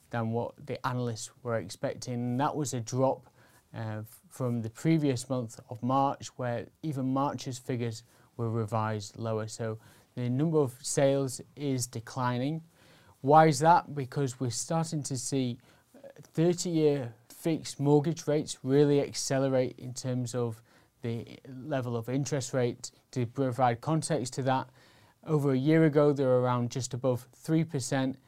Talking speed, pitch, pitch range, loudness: 145 wpm, 130 Hz, 120-145 Hz, -30 LUFS